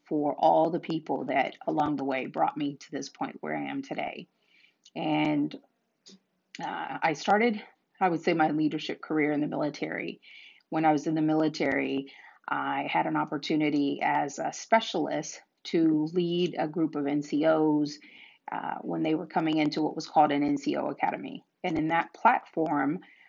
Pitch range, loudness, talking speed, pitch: 150-165 Hz, -28 LUFS, 165 wpm, 155 Hz